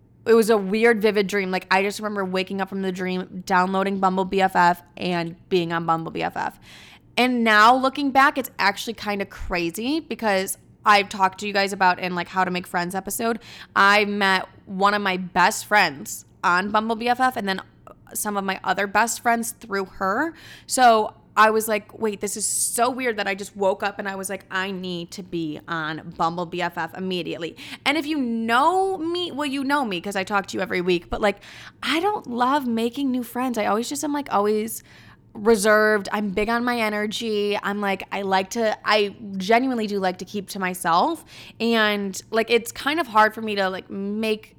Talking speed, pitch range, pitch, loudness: 205 wpm, 190-230 Hz, 205 Hz, -22 LUFS